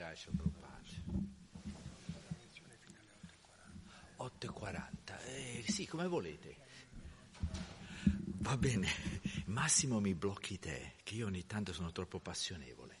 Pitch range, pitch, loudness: 95-135 Hz, 105 Hz, -41 LUFS